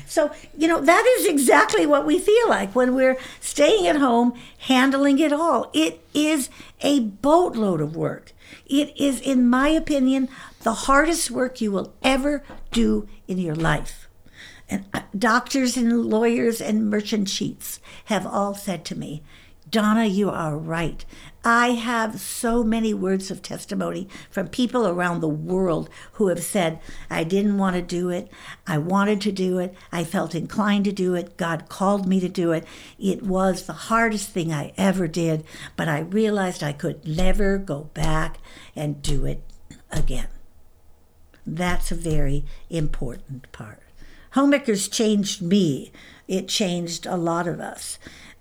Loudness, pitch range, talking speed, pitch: -22 LUFS, 165-245 Hz, 155 wpm, 195 Hz